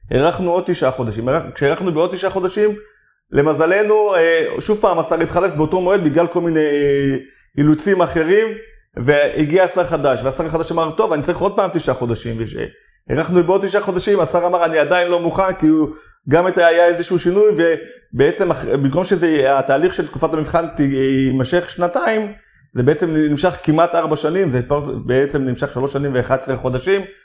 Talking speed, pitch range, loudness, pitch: 160 wpm, 140-185 Hz, -17 LUFS, 165 Hz